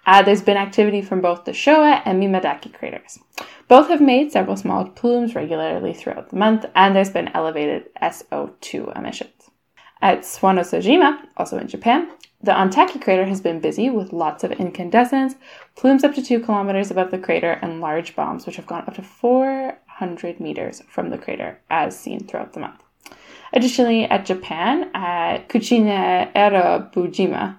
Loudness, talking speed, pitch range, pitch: -18 LUFS, 160 wpm, 185-250 Hz, 200 Hz